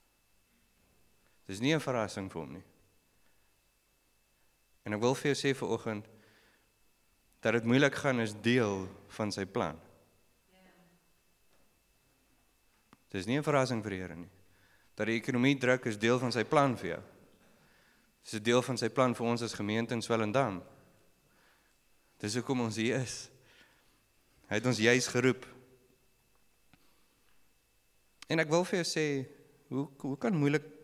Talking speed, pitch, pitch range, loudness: 145 wpm, 120 Hz, 105-135 Hz, -32 LUFS